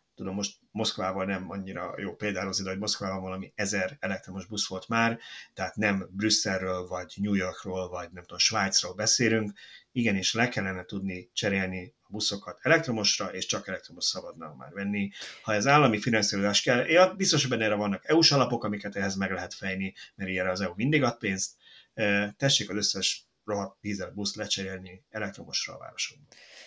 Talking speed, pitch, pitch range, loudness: 165 wpm, 100 Hz, 95-110 Hz, -28 LUFS